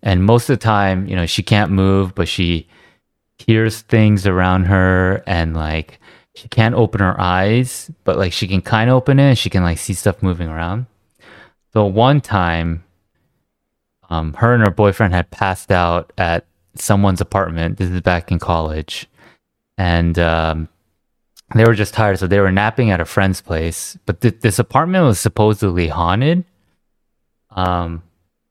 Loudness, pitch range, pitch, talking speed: -16 LUFS, 85-110 Hz, 95 Hz, 170 wpm